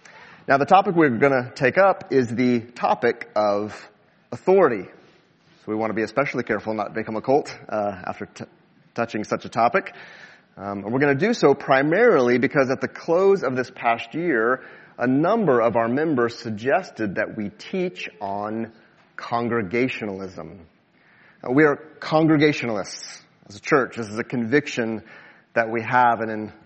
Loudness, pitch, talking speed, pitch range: -22 LUFS, 120 Hz, 165 wpm, 110-140 Hz